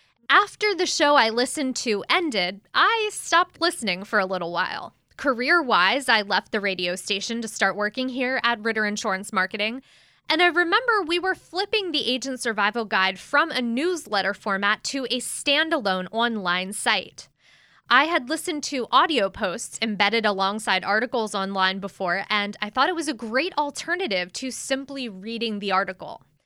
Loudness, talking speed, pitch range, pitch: -23 LUFS, 165 wpm, 200-300 Hz, 235 Hz